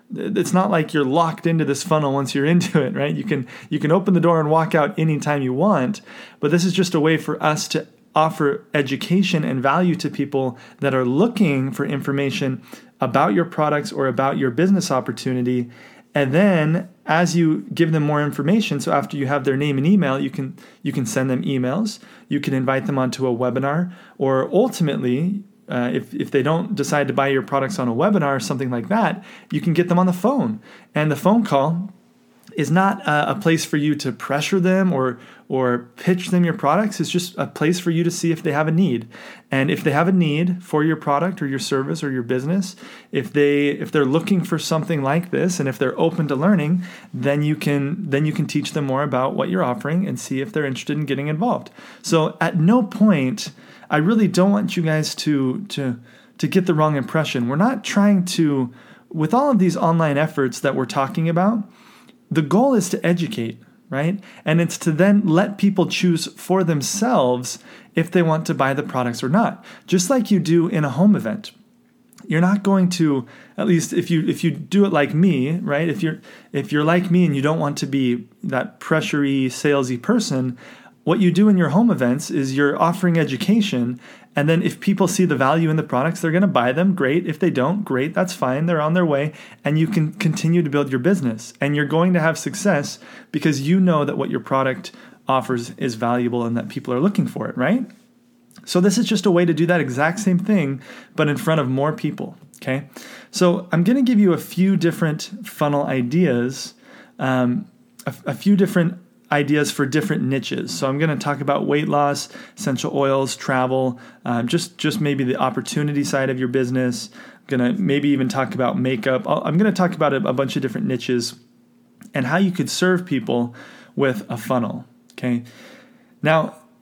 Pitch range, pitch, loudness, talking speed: 140-190 Hz, 160 Hz, -20 LUFS, 210 wpm